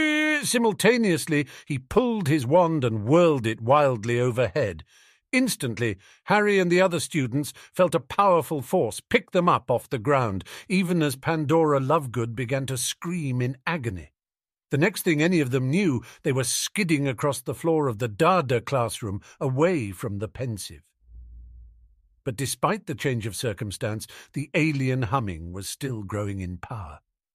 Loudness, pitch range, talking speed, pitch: -24 LUFS, 115-165 Hz, 155 wpm, 140 Hz